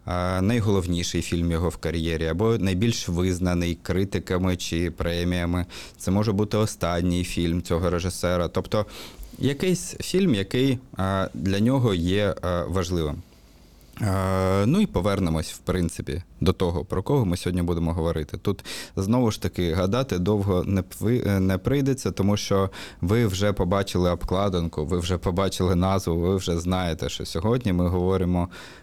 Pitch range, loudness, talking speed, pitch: 85-100 Hz, -25 LUFS, 135 wpm, 95 Hz